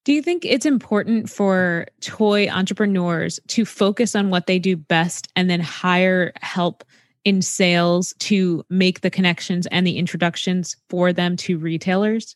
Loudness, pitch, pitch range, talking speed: -19 LUFS, 185 Hz, 175-205 Hz, 155 wpm